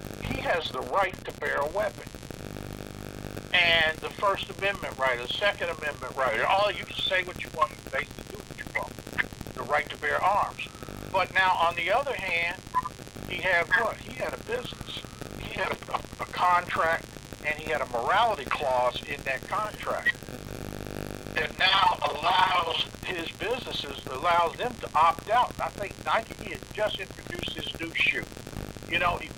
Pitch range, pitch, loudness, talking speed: 130-180 Hz, 155 Hz, -27 LUFS, 170 wpm